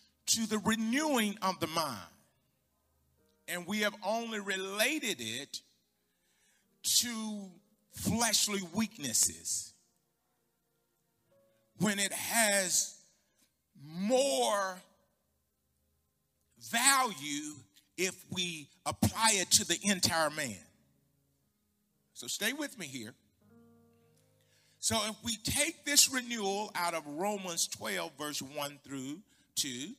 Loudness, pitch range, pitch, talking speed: -31 LUFS, 135-220 Hz, 190 Hz, 95 wpm